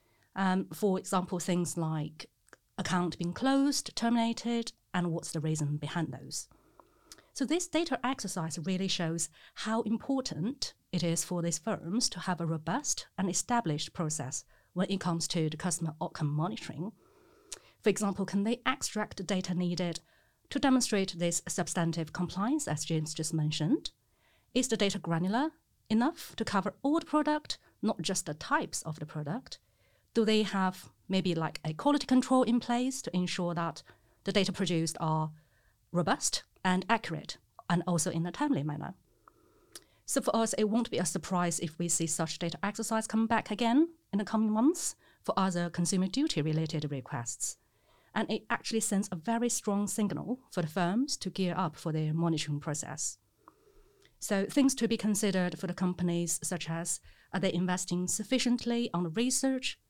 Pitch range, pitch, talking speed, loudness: 165-230 Hz, 185 Hz, 165 wpm, -32 LUFS